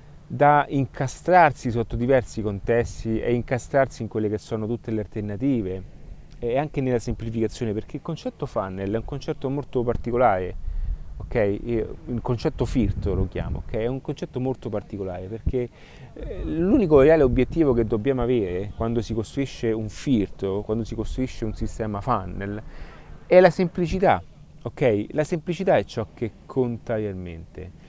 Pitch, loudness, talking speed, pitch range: 115 Hz, -24 LUFS, 145 wpm, 105-135 Hz